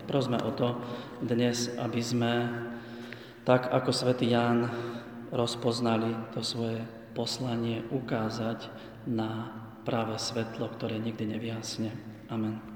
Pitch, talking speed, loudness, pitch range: 115 Hz, 105 wpm, -31 LUFS, 115-120 Hz